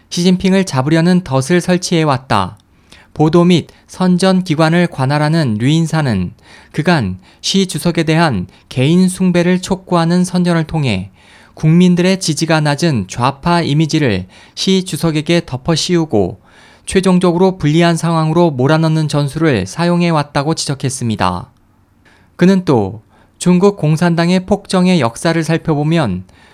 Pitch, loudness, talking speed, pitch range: 160 Hz, -13 LUFS, 290 characters per minute, 130-175 Hz